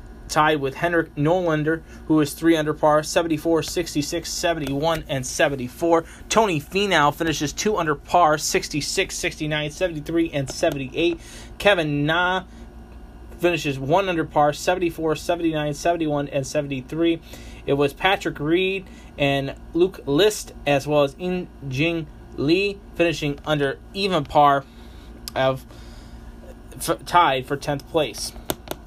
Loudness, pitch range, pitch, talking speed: -22 LUFS, 140-170 Hz, 155 Hz, 120 wpm